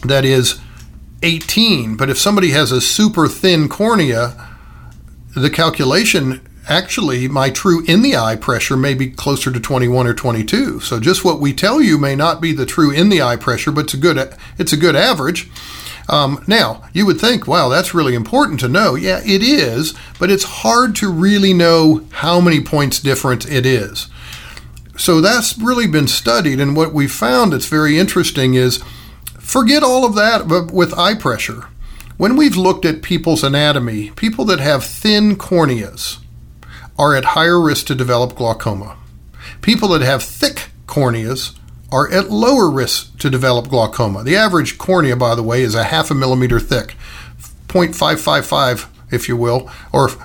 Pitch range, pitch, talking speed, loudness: 120-175 Hz, 140 Hz, 170 wpm, -14 LUFS